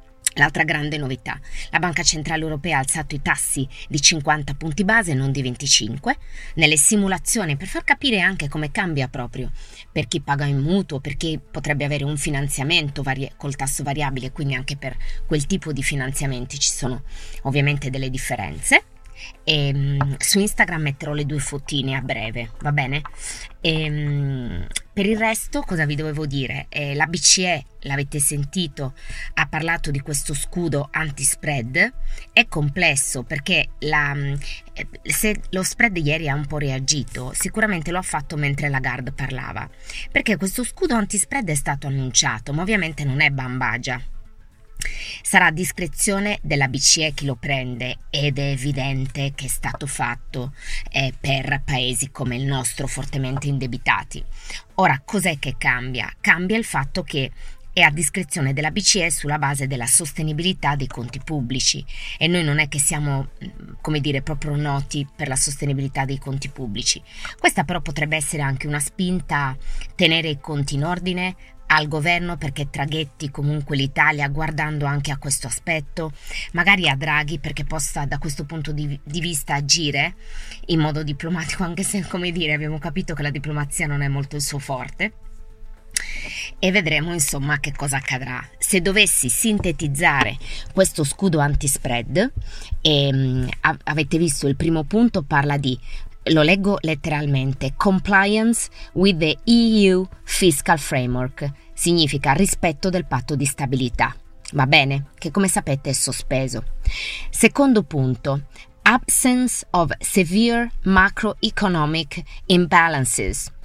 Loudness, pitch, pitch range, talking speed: -20 LUFS, 145 Hz, 135-170 Hz, 145 wpm